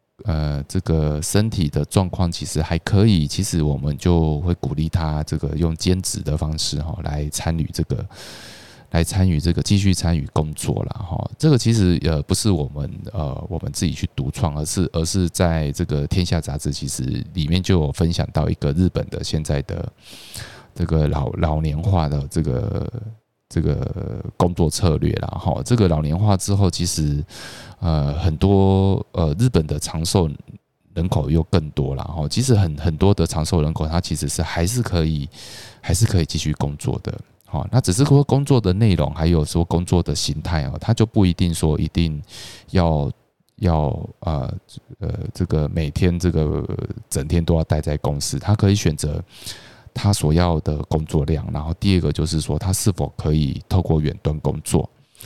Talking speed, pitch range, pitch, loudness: 260 characters per minute, 75-100 Hz, 85 Hz, -21 LUFS